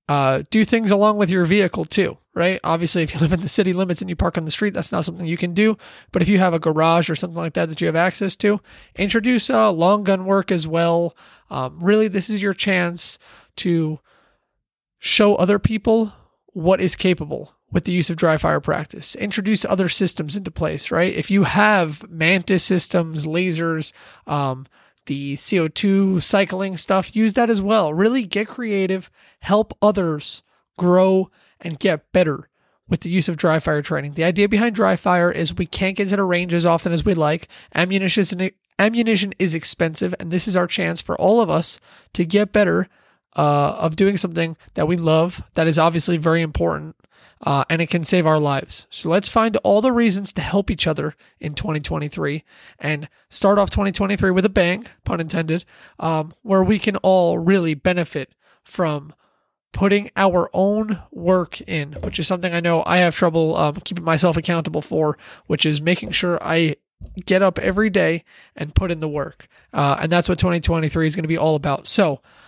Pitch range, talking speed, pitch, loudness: 160-195 Hz, 195 wpm, 180 Hz, -19 LUFS